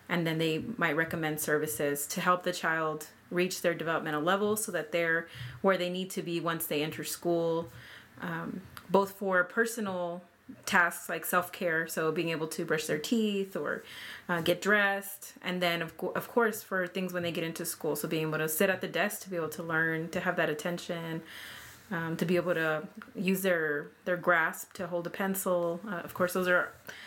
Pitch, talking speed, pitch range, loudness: 175 Hz, 205 wpm, 165-185 Hz, -31 LUFS